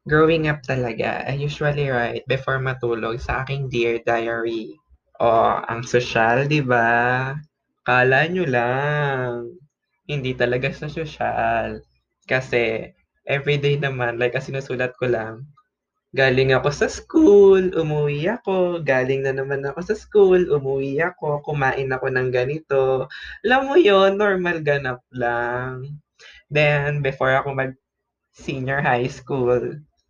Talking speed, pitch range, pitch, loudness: 120 wpm, 125-150 Hz, 135 Hz, -20 LUFS